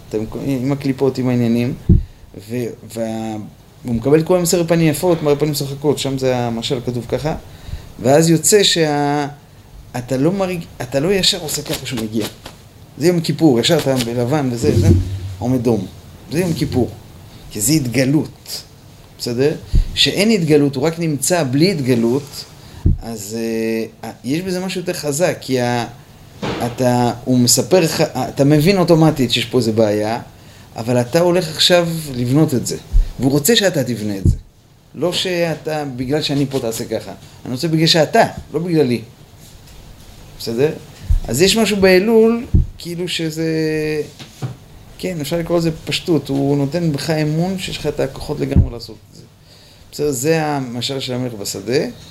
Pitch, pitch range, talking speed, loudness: 140 Hz, 120-160 Hz, 150 wpm, -17 LUFS